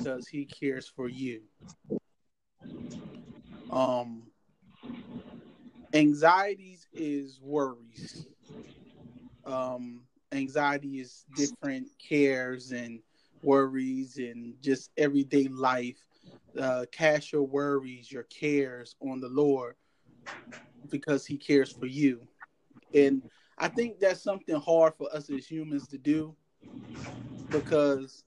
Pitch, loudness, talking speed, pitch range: 140 Hz, -29 LUFS, 100 wpm, 130-155 Hz